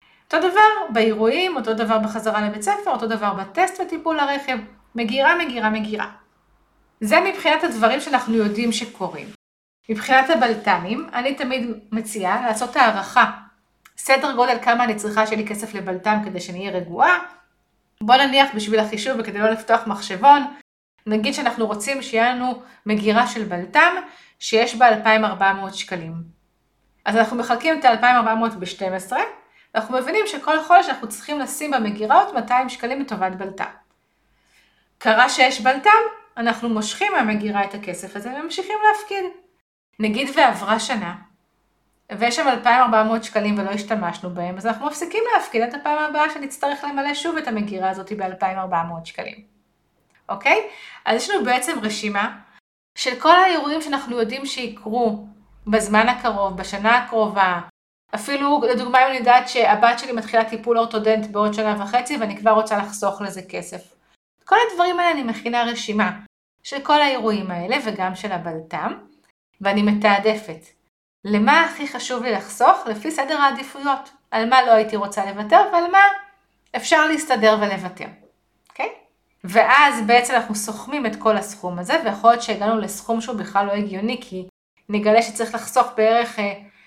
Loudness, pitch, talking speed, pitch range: -19 LUFS, 230 Hz, 145 wpm, 210-270 Hz